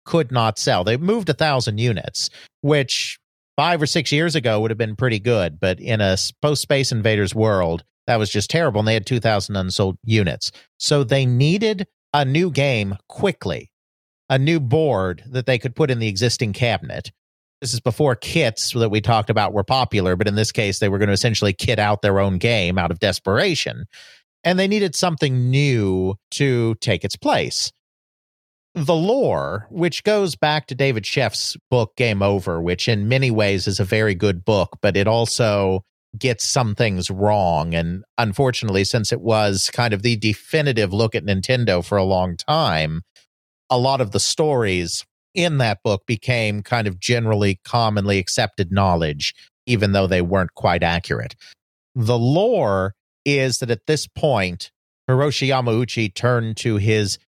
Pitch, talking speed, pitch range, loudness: 110 Hz, 175 wpm, 100-130 Hz, -19 LUFS